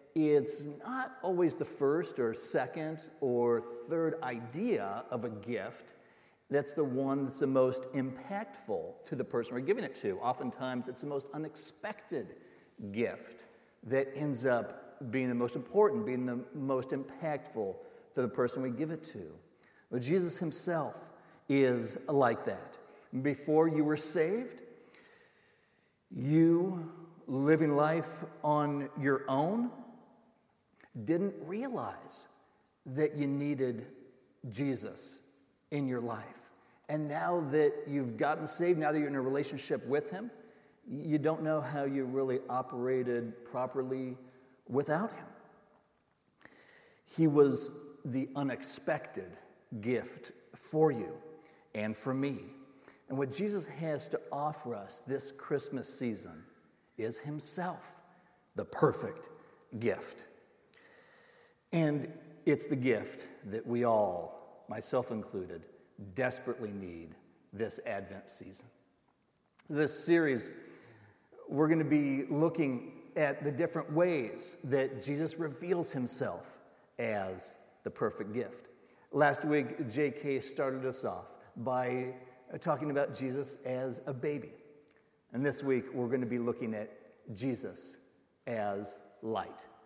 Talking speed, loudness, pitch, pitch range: 120 wpm, -34 LUFS, 145 Hz, 130-160 Hz